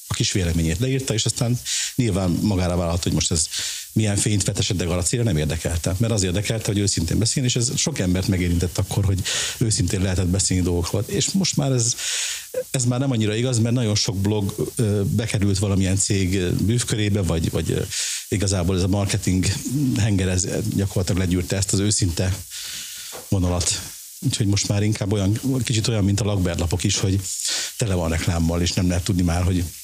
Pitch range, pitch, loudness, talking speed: 90-115 Hz, 100 Hz, -21 LUFS, 180 wpm